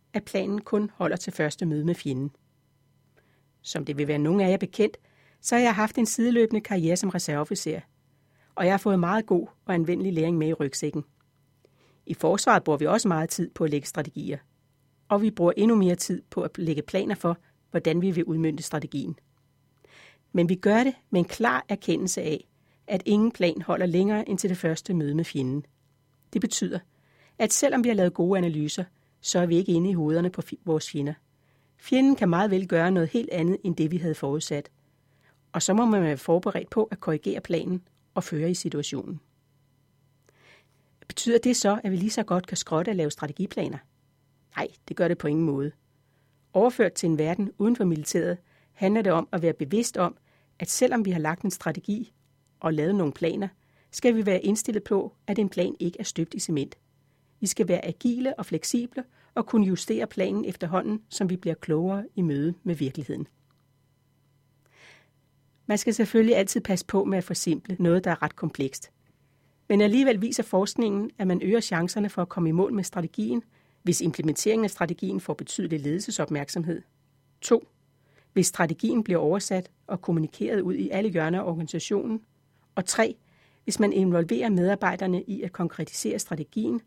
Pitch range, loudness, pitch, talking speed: 145-195 Hz, -26 LUFS, 170 Hz, 185 wpm